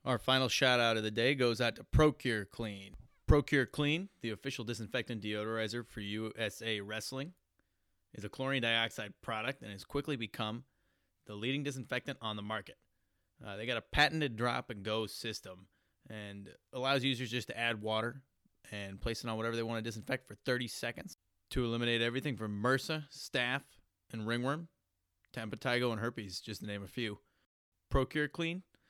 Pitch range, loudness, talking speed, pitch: 105-130 Hz, -35 LUFS, 170 wpm, 115 Hz